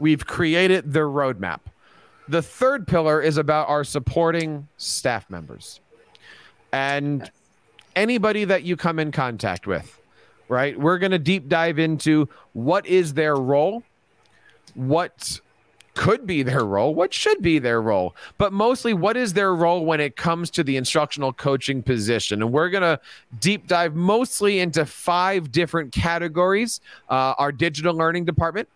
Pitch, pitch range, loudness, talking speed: 165 Hz, 140-185 Hz, -21 LUFS, 145 wpm